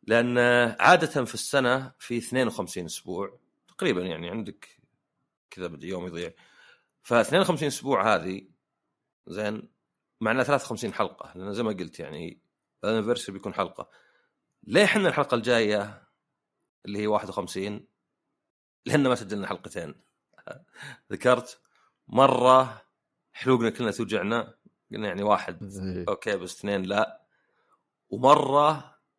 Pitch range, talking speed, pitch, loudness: 105-135 Hz, 110 wpm, 120 Hz, -25 LUFS